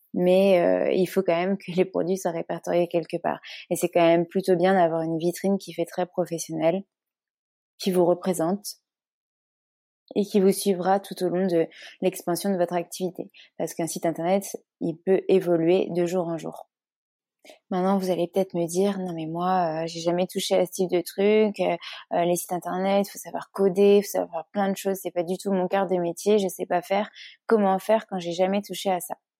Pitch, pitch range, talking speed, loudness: 185 Hz, 175-195 Hz, 215 wpm, -25 LUFS